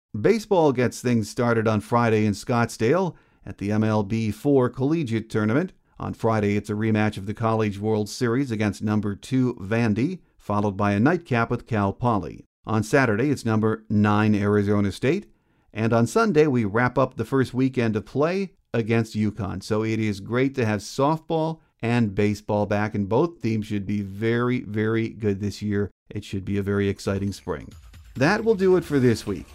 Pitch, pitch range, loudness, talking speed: 110 Hz, 105-125 Hz, -23 LUFS, 180 wpm